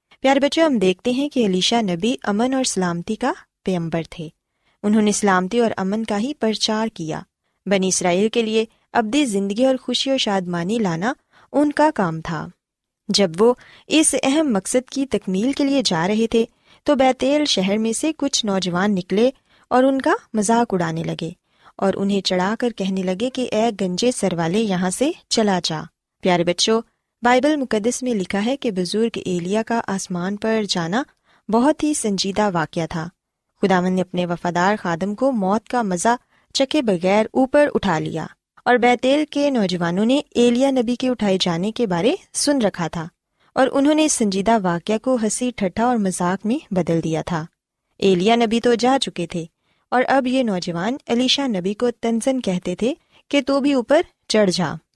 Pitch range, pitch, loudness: 185-255 Hz, 220 Hz, -20 LUFS